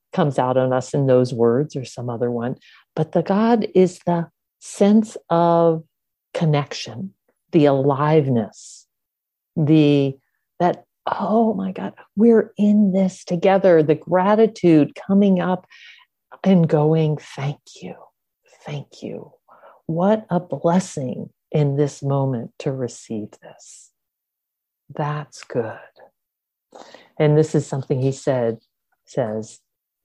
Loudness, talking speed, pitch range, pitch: -19 LUFS, 115 wpm, 140-185 Hz, 155 Hz